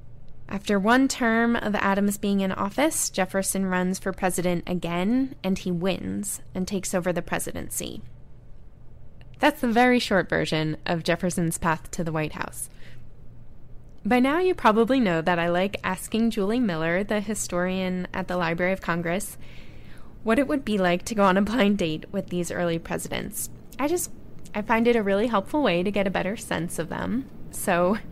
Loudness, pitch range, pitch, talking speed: -25 LUFS, 175-220 Hz, 190 Hz, 175 wpm